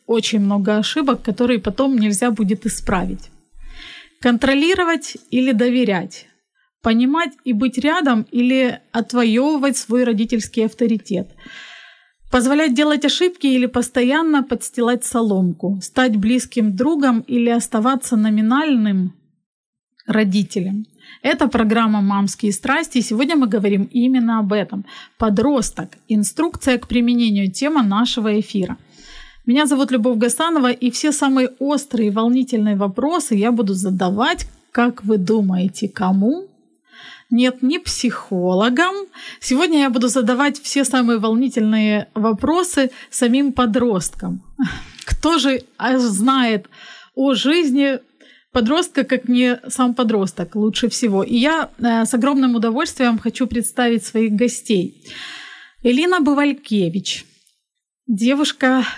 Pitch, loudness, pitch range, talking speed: 245 Hz, -18 LUFS, 220-275 Hz, 110 wpm